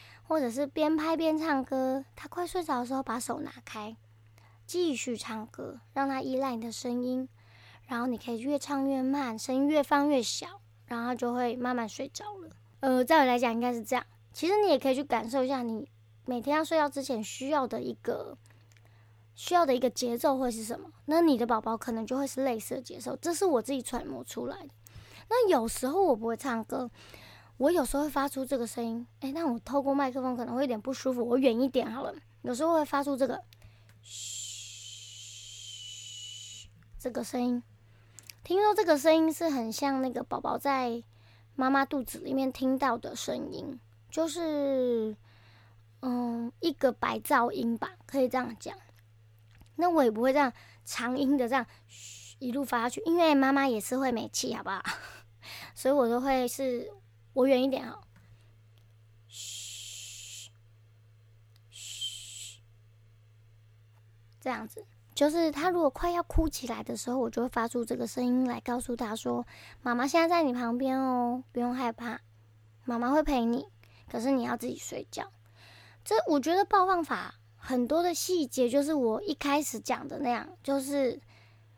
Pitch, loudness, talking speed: 245 Hz, -30 LUFS, 250 characters per minute